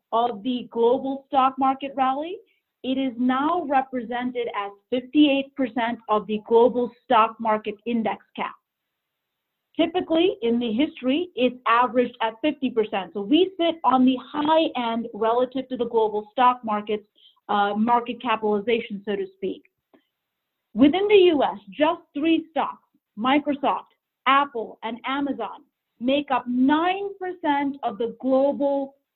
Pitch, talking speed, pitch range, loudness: 255 Hz, 130 wpm, 230-280 Hz, -23 LUFS